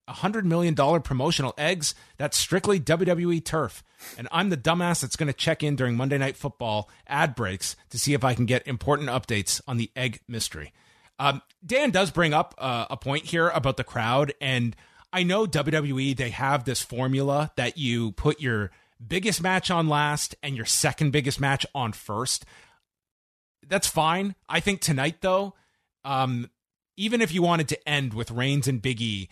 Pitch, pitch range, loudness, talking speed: 140 Hz, 125-165 Hz, -25 LUFS, 175 wpm